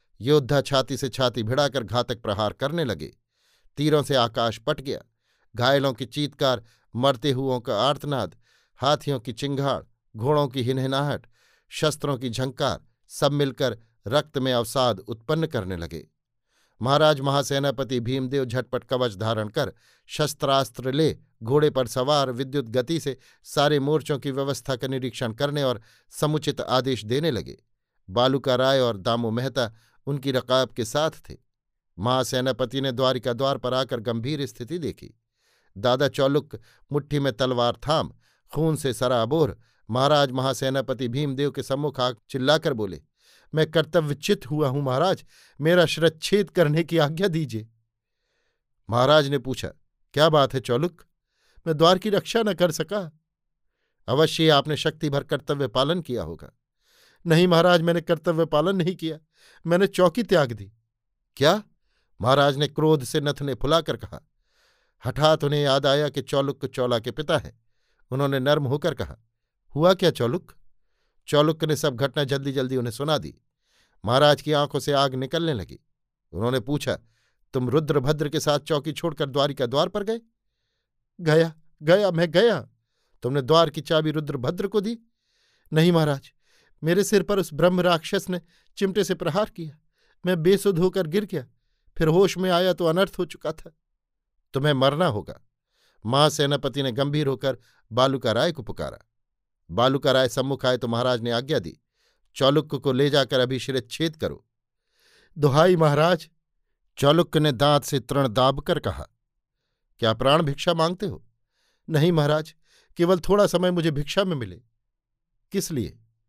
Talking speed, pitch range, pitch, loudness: 150 wpm, 125-155 Hz, 140 Hz, -23 LUFS